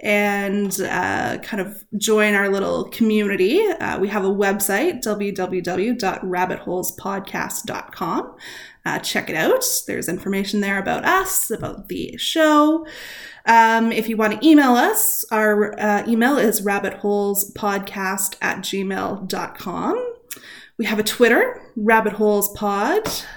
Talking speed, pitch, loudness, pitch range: 115 wpm, 210 Hz, -19 LUFS, 195-245 Hz